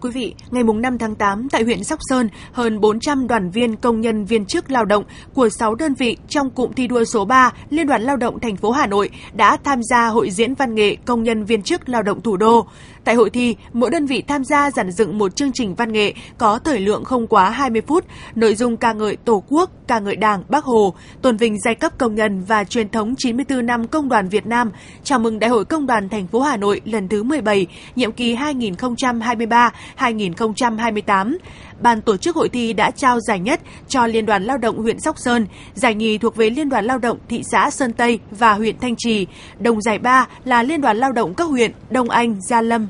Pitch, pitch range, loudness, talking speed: 235 Hz, 220-255 Hz, -18 LUFS, 230 wpm